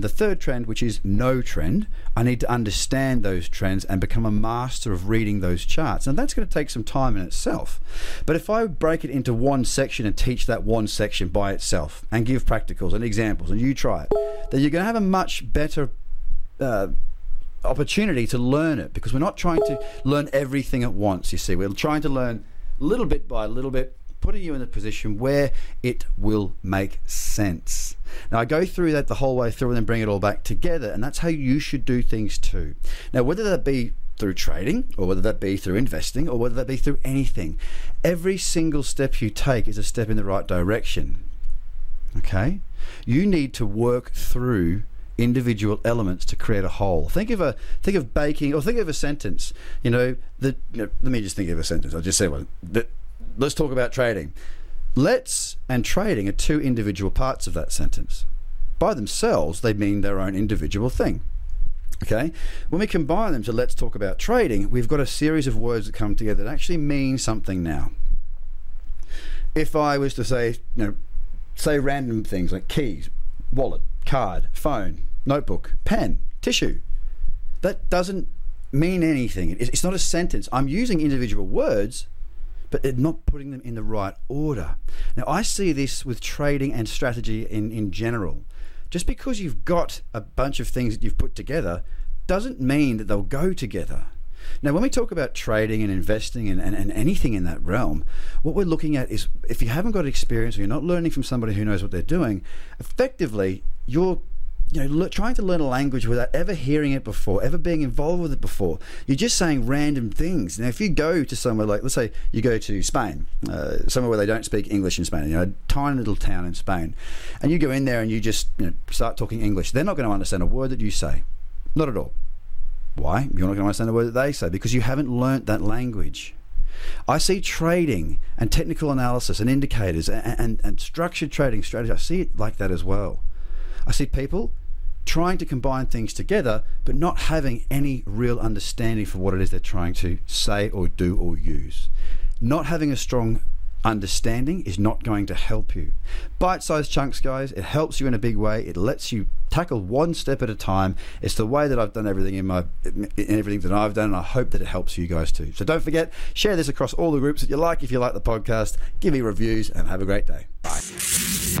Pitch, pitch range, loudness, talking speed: 110 Hz, 95-140 Hz, -25 LUFS, 210 wpm